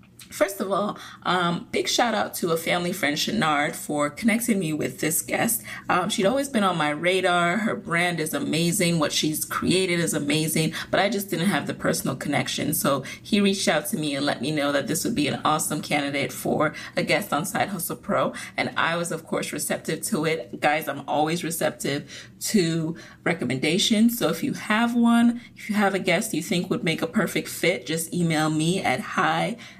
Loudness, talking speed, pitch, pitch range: -24 LUFS, 205 wpm, 170 Hz, 155-200 Hz